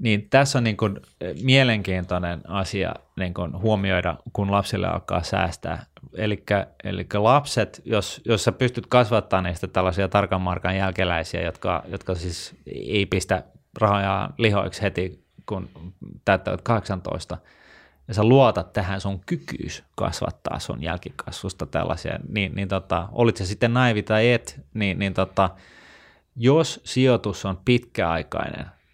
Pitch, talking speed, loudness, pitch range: 100 Hz, 130 wpm, -23 LUFS, 90-110 Hz